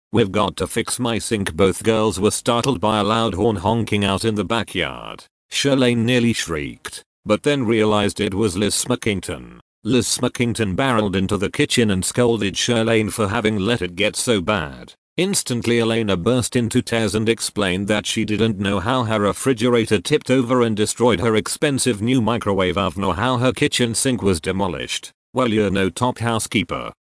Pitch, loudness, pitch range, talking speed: 110 Hz, -19 LUFS, 100-120 Hz, 175 wpm